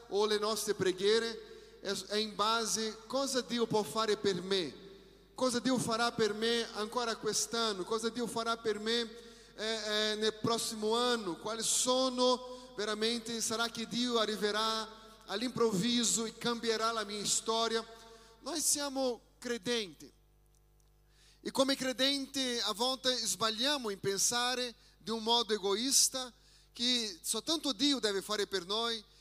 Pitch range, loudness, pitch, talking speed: 215-240 Hz, -33 LUFS, 225 Hz, 145 wpm